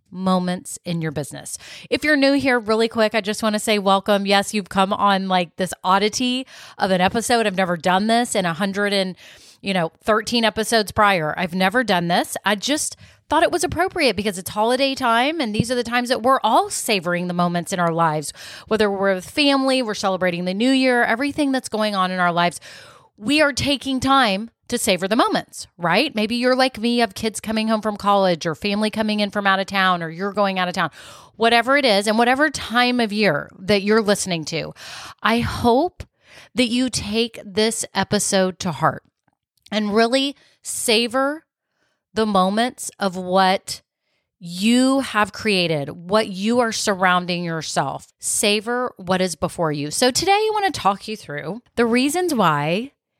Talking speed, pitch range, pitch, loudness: 190 wpm, 185-245 Hz, 210 Hz, -20 LUFS